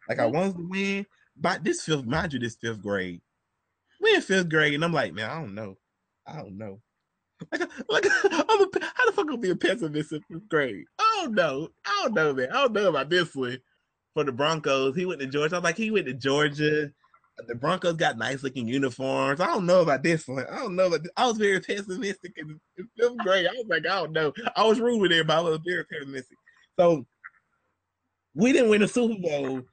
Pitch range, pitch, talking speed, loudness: 135-200 Hz, 165 Hz, 230 wpm, -25 LUFS